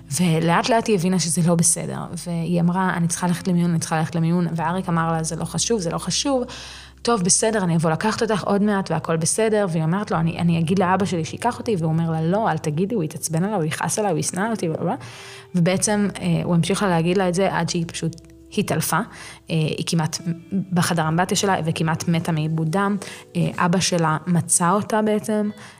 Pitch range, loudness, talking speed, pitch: 165-195 Hz, -21 LUFS, 200 wpm, 175 Hz